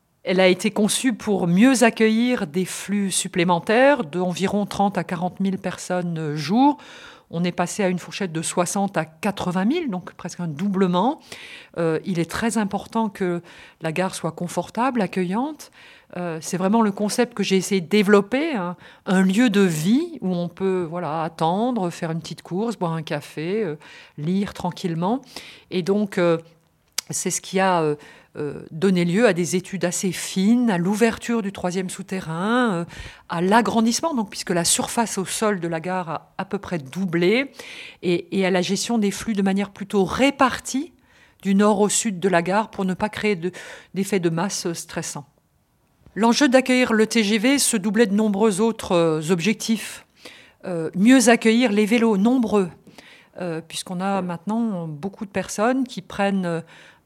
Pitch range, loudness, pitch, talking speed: 175-225 Hz, -22 LUFS, 195 Hz, 175 wpm